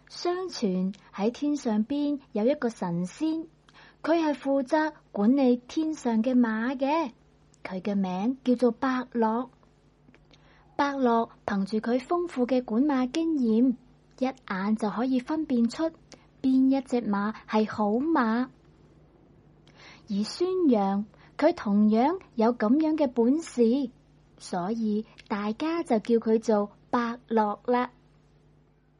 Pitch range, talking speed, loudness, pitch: 210-275 Hz, 165 characters per minute, -27 LUFS, 240 Hz